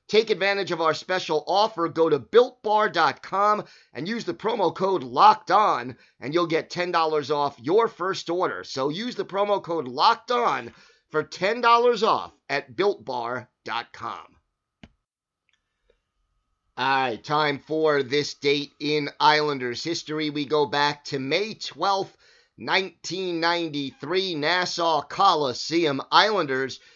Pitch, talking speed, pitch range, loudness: 170 Hz, 120 wpm, 150-195 Hz, -23 LUFS